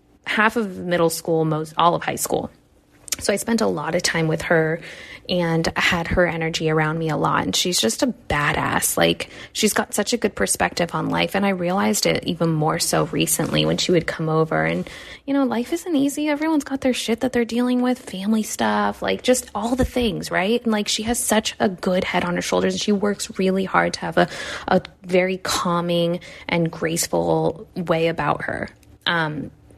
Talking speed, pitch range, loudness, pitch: 210 wpm, 165-230 Hz, -21 LUFS, 185 Hz